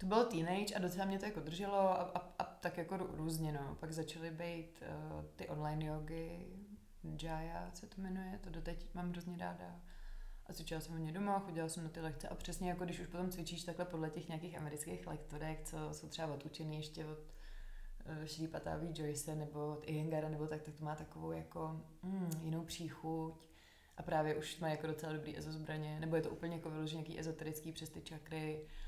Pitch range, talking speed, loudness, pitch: 155-175 Hz, 200 wpm, -44 LUFS, 160 Hz